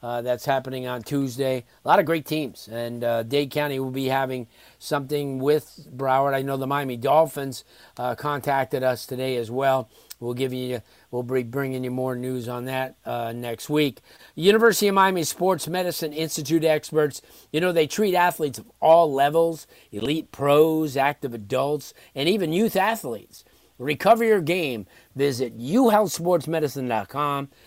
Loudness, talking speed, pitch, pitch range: -23 LUFS, 160 wpm, 140 Hz, 130-160 Hz